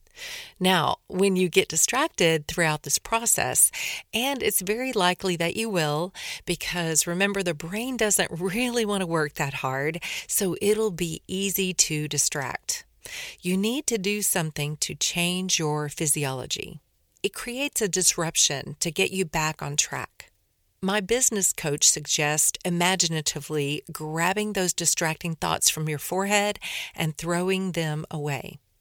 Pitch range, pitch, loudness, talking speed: 155-205 Hz, 180 Hz, -24 LUFS, 140 wpm